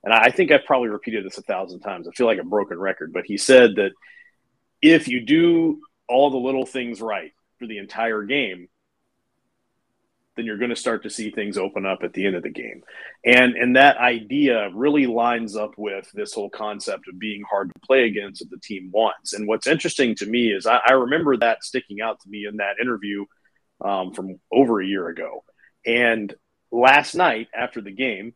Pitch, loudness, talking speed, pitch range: 115 Hz, -20 LUFS, 205 wpm, 105-135 Hz